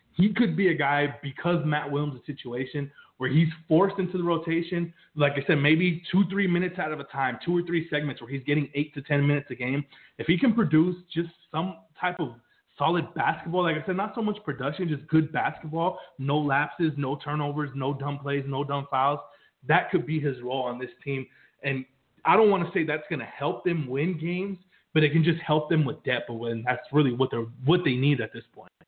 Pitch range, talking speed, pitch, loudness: 140-170 Hz, 230 wpm, 150 Hz, -27 LUFS